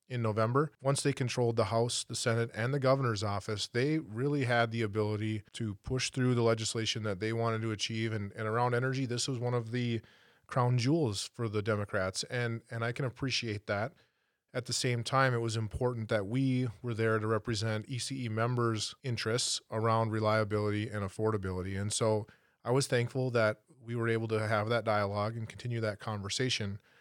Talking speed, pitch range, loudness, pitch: 190 wpm, 110-125 Hz, -33 LUFS, 115 Hz